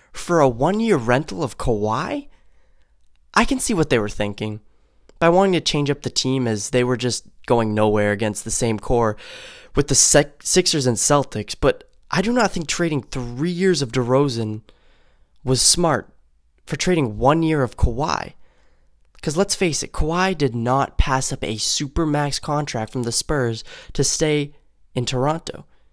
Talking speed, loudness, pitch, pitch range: 175 wpm, -20 LUFS, 135 Hz, 115-160 Hz